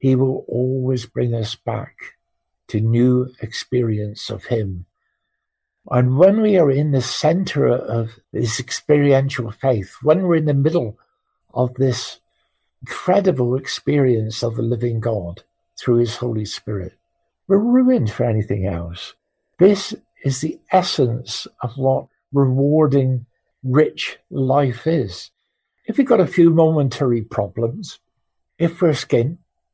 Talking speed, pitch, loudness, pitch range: 130 wpm, 130 Hz, -19 LUFS, 115-155 Hz